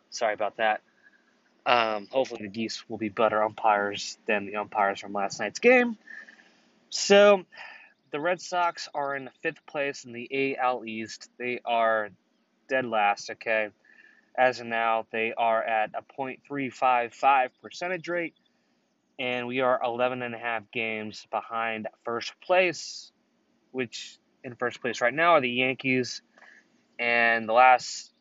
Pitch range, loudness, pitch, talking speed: 110-135 Hz, -26 LUFS, 120 Hz, 140 wpm